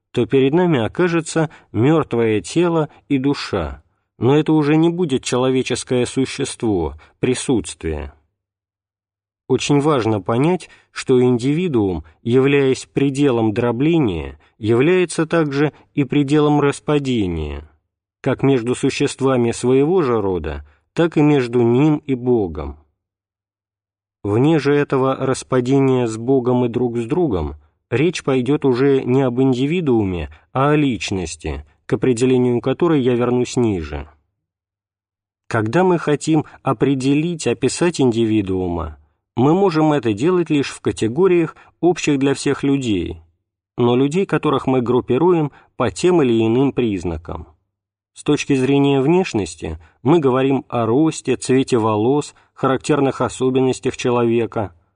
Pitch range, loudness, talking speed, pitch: 100-145 Hz, -18 LUFS, 115 wpm, 125 Hz